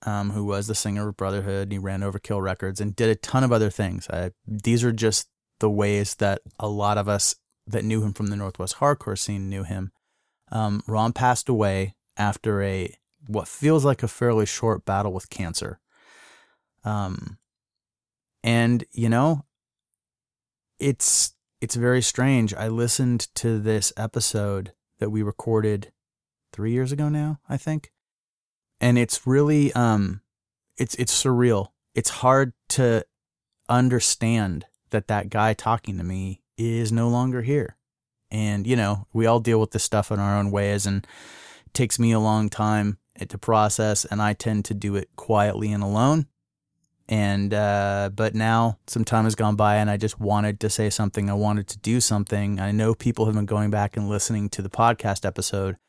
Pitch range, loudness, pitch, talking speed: 100-115 Hz, -23 LUFS, 110 Hz, 175 wpm